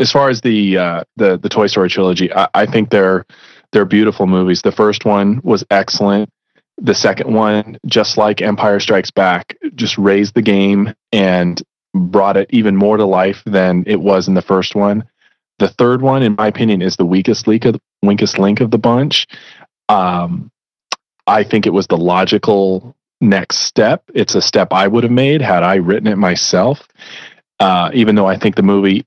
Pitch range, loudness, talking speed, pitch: 95-110 Hz, -13 LUFS, 190 wpm, 100 Hz